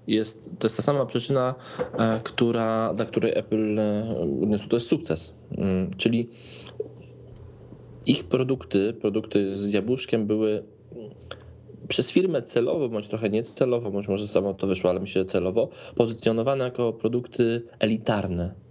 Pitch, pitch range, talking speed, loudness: 110 Hz, 100-120 Hz, 120 wpm, -26 LUFS